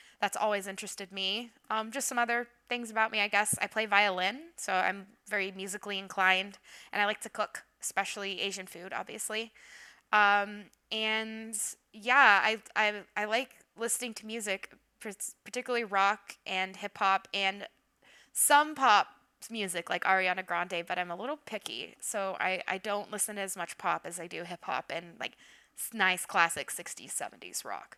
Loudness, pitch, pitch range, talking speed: -31 LUFS, 205 Hz, 195-225 Hz, 165 wpm